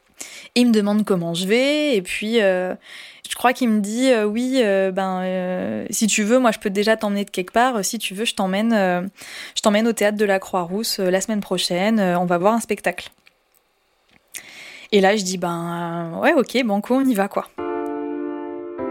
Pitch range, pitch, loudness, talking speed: 185-225 Hz, 205 Hz, -20 LUFS, 215 wpm